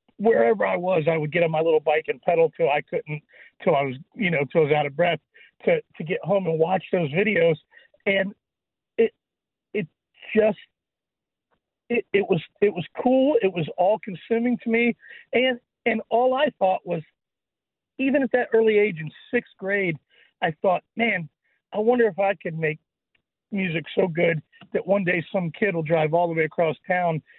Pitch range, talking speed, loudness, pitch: 165-230 Hz, 195 wpm, -23 LUFS, 190 Hz